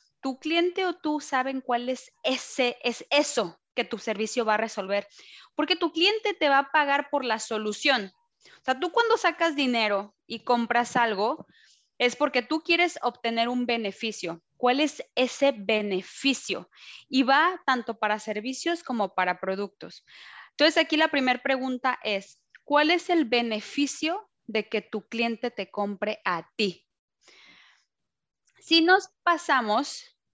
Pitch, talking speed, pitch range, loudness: 250 Hz, 150 wpm, 215-305 Hz, -26 LUFS